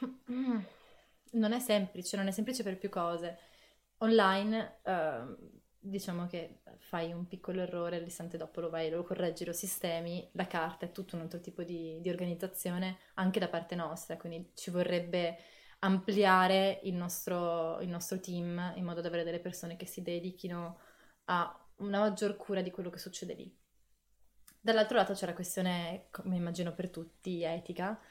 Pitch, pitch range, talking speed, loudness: 180 Hz, 170-195 Hz, 165 wpm, -35 LUFS